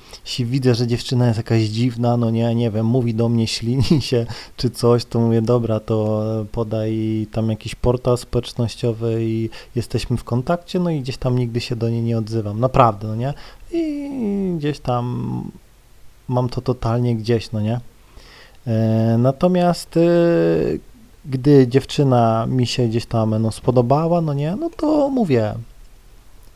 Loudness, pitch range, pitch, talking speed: -19 LUFS, 115-130 Hz, 120 Hz, 150 wpm